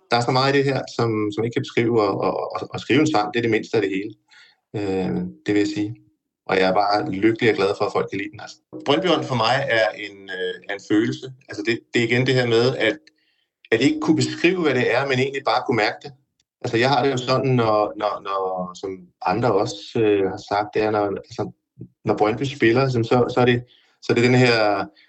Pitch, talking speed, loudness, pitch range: 110 Hz, 255 wpm, -21 LUFS, 100-130 Hz